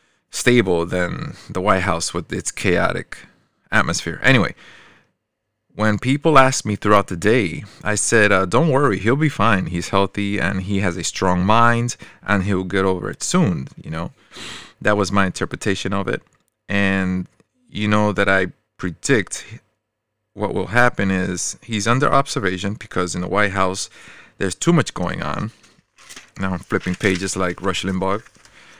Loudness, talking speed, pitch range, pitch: -19 LUFS, 160 wpm, 95-110 Hz, 100 Hz